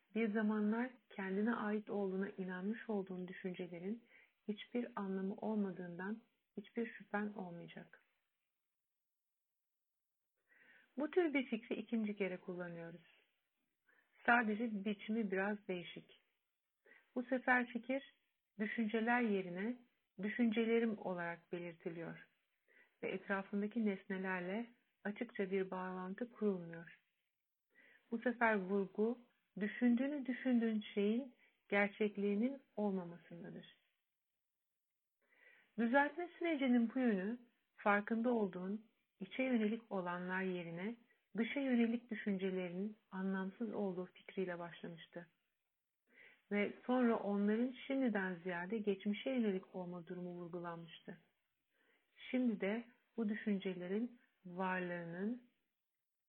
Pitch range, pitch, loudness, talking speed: 190-240 Hz, 210 Hz, -41 LUFS, 85 wpm